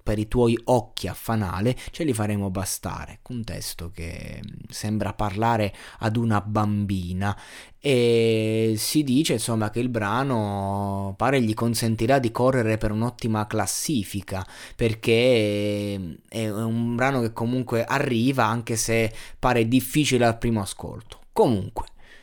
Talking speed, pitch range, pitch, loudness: 130 wpm, 105-120 Hz, 110 Hz, -24 LUFS